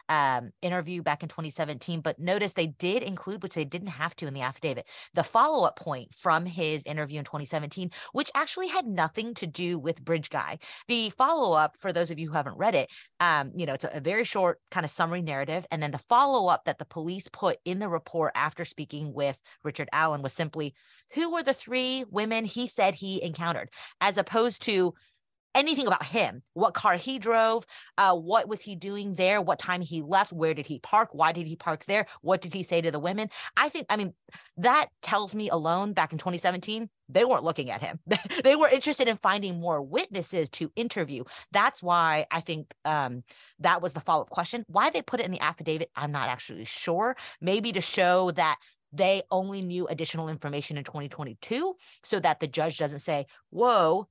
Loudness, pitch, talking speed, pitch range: -28 LUFS, 175 Hz, 210 wpm, 155-205 Hz